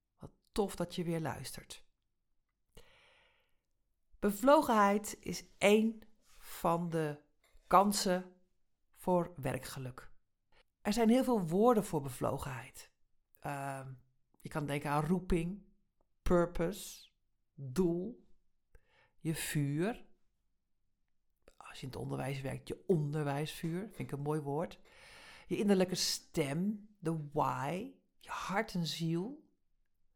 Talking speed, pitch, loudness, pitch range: 105 wpm, 180 Hz, -35 LUFS, 150-205 Hz